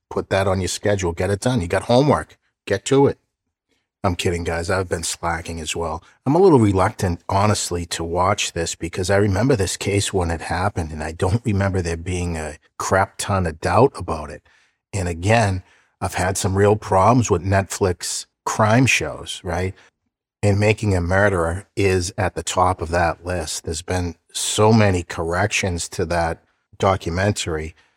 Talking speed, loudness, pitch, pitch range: 175 wpm, -20 LUFS, 95 Hz, 85-100 Hz